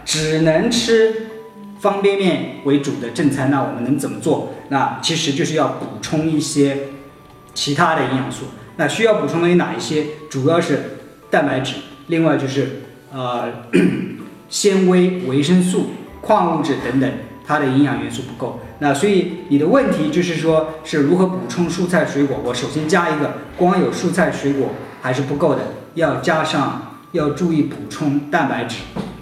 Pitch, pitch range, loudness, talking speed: 155 Hz, 140-175 Hz, -18 LUFS, 245 characters per minute